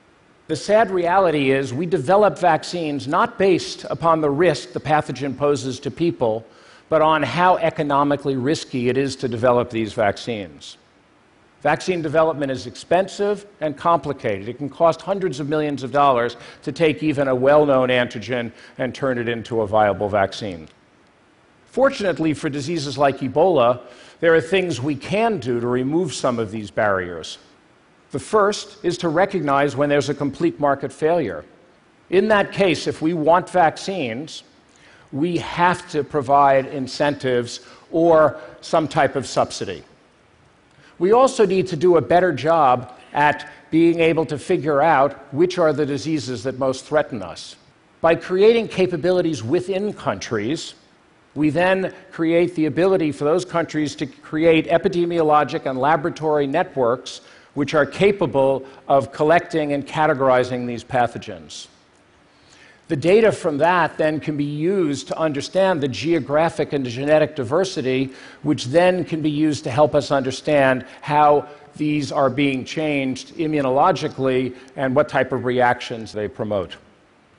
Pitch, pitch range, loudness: 150 Hz, 135-170 Hz, -20 LUFS